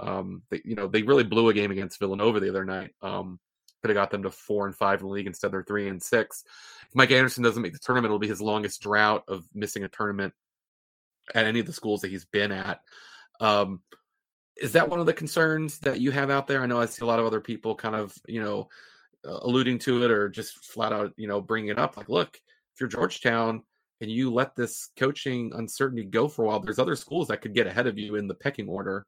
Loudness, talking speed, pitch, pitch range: -27 LUFS, 255 wpm, 110 Hz, 105-125 Hz